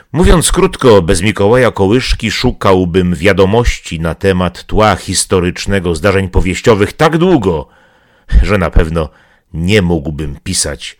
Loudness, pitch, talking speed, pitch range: -11 LUFS, 95 Hz, 115 wpm, 85-110 Hz